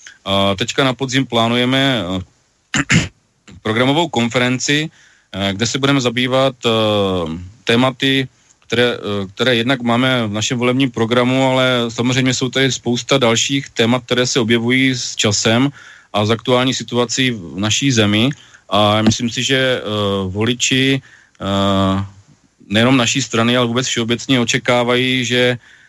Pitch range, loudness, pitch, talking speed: 110-130 Hz, -16 LUFS, 120 Hz, 120 wpm